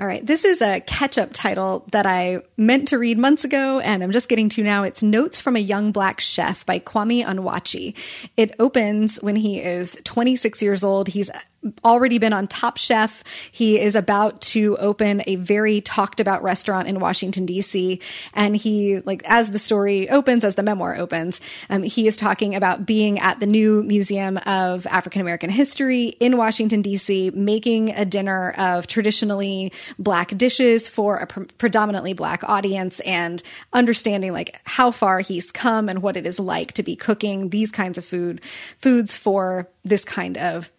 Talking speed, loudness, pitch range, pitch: 180 wpm, -20 LUFS, 190-225 Hz, 205 Hz